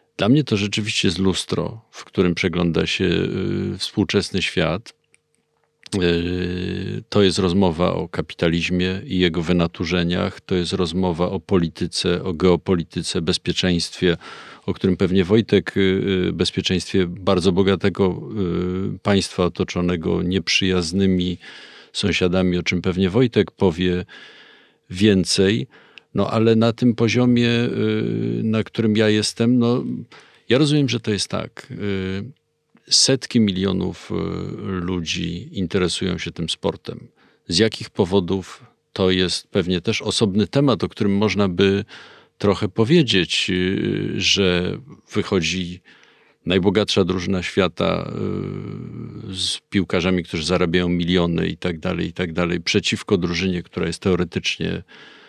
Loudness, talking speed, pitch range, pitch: -20 LUFS, 110 wpm, 90-105 Hz, 95 Hz